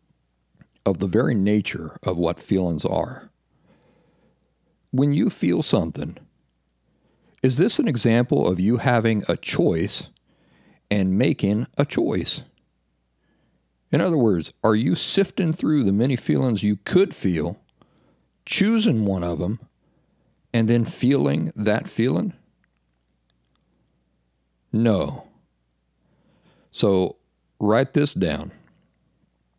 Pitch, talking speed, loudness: 95 Hz, 105 wpm, -22 LUFS